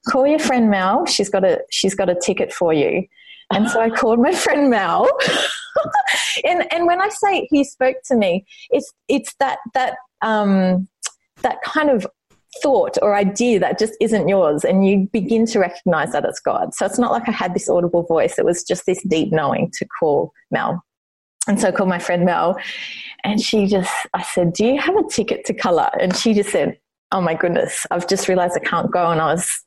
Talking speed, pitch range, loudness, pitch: 210 wpm, 190-270 Hz, -18 LUFS, 220 Hz